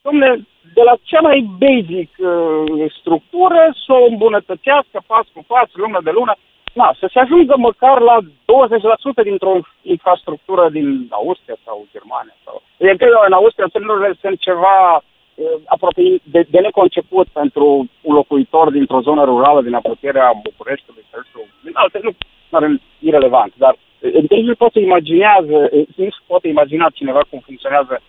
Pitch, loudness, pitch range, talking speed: 195 Hz, -13 LUFS, 165-265 Hz, 145 wpm